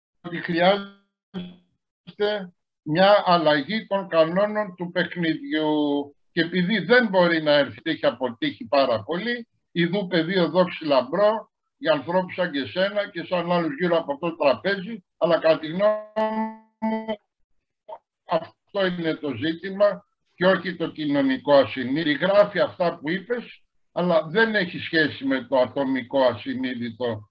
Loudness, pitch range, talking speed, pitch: -23 LUFS, 155-205 Hz, 130 wpm, 180 Hz